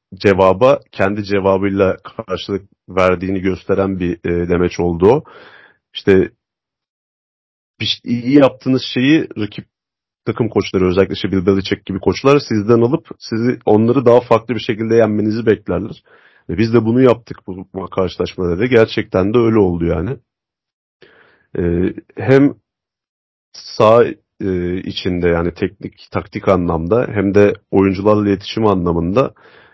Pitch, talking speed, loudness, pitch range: 100 Hz, 125 wpm, -15 LUFS, 95-115 Hz